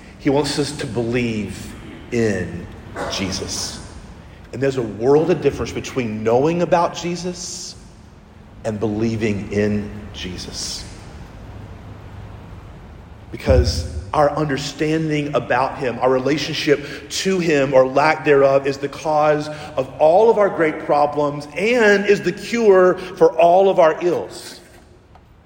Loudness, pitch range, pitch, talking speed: -18 LUFS, 105-155 Hz, 130 Hz, 120 wpm